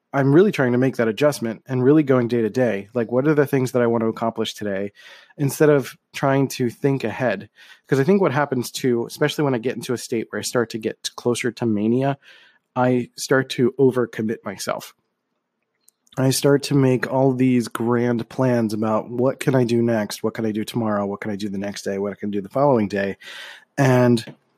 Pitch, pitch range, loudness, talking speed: 125 Hz, 110-135 Hz, -21 LUFS, 220 wpm